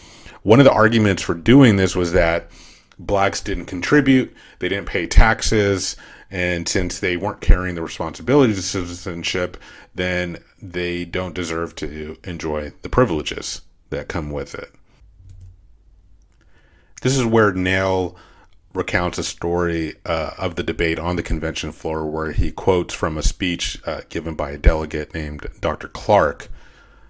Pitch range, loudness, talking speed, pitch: 80-95 Hz, -20 LUFS, 145 wpm, 90 Hz